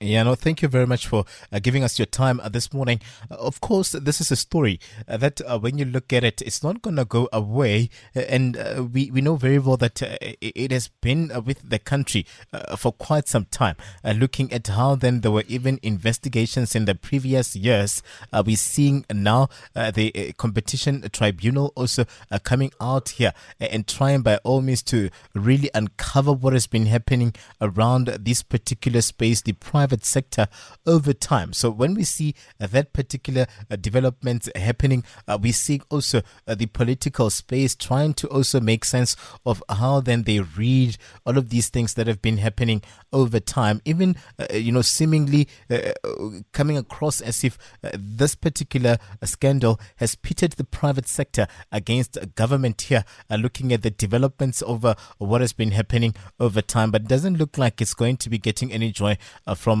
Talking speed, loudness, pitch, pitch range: 195 wpm, -22 LUFS, 120 Hz, 110-135 Hz